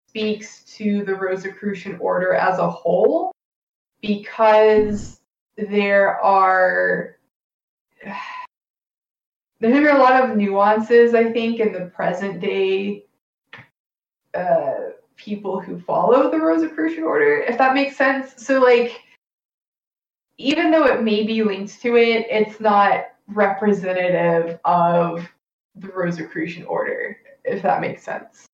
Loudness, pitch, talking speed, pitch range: -18 LUFS, 215 Hz, 115 wpm, 195-265 Hz